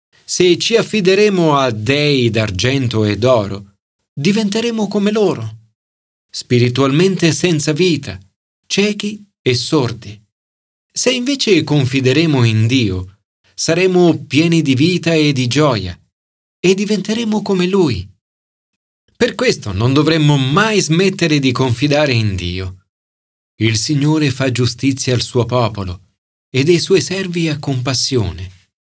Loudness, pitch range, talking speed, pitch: -14 LUFS, 105-175 Hz, 115 wpm, 135 Hz